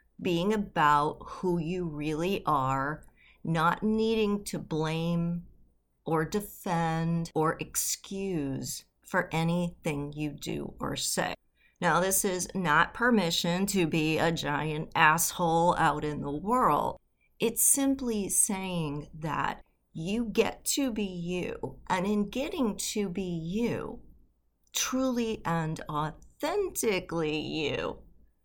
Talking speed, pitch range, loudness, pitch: 110 wpm, 155-205 Hz, -29 LUFS, 170 Hz